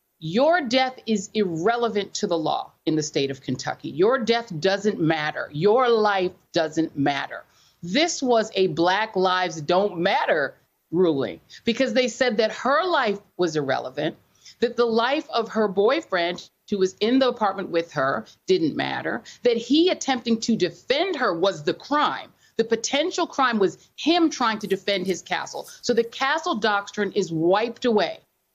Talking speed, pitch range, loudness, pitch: 160 wpm, 180-250 Hz, -23 LUFS, 210 Hz